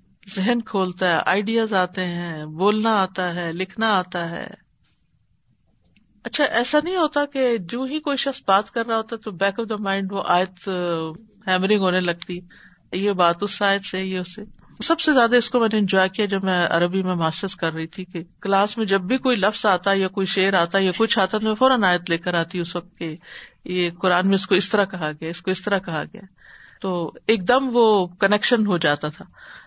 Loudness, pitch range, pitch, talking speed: -21 LUFS, 180-220 Hz, 195 Hz, 215 wpm